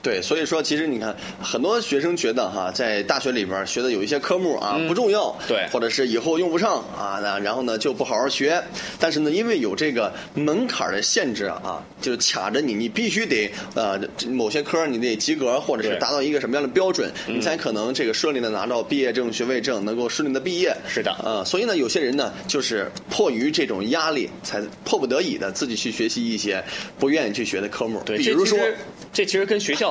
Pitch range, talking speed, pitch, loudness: 130-220 Hz, 335 characters per minute, 165 Hz, -23 LUFS